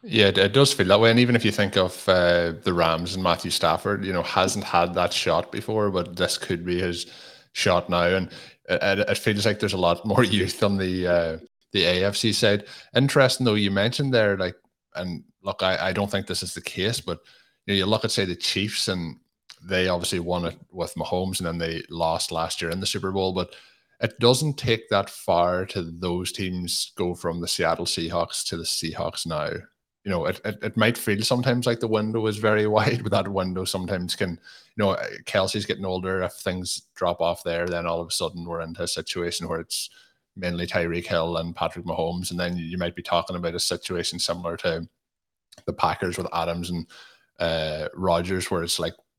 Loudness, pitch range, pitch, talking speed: -24 LUFS, 85-105 Hz, 90 Hz, 215 wpm